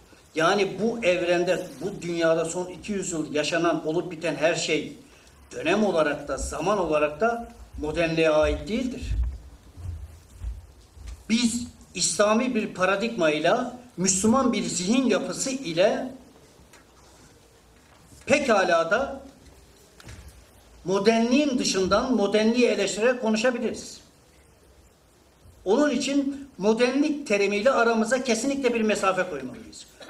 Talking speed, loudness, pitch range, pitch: 95 wpm, -24 LUFS, 165-235 Hz, 200 Hz